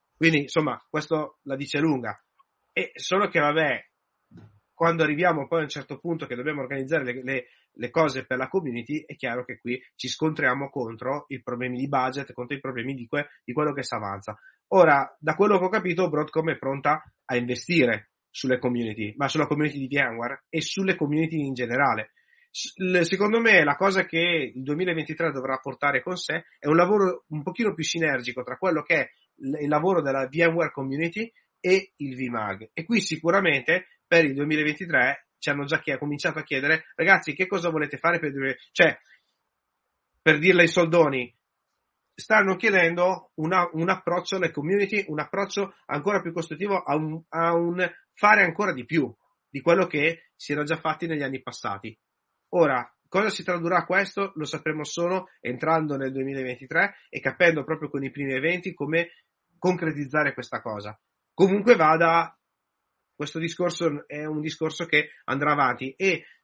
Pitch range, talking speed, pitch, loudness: 135-175 Hz, 175 wpm, 155 Hz, -25 LUFS